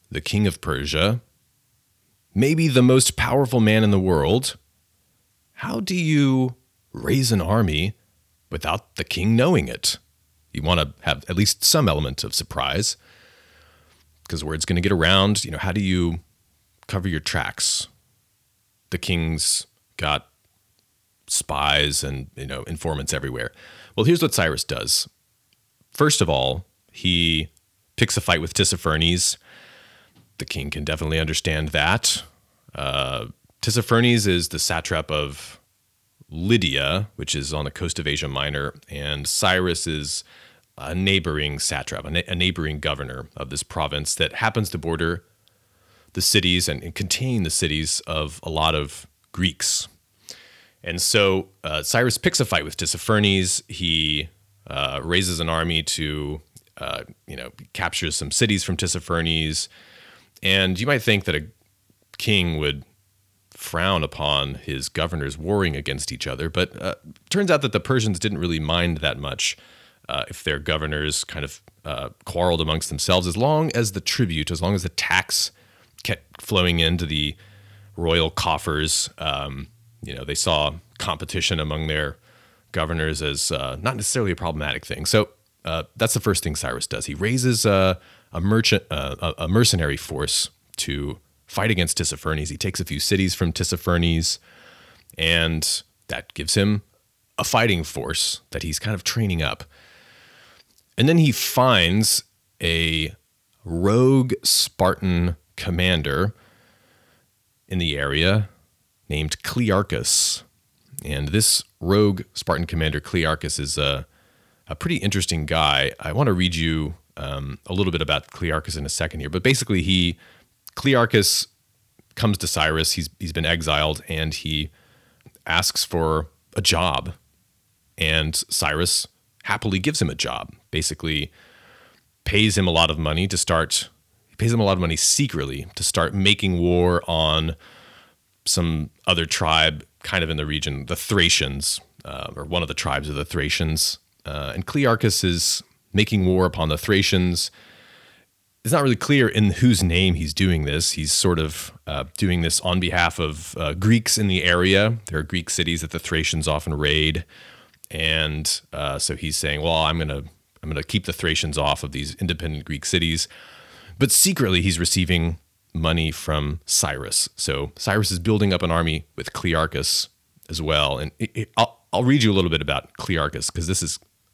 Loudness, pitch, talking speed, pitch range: -21 LUFS, 85 Hz, 155 wpm, 80-100 Hz